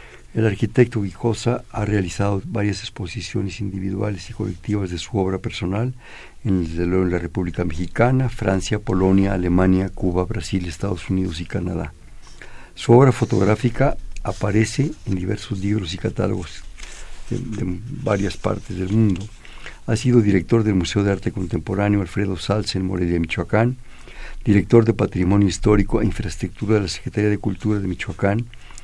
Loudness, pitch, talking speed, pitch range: -21 LUFS, 100 Hz, 145 wpm, 90-110 Hz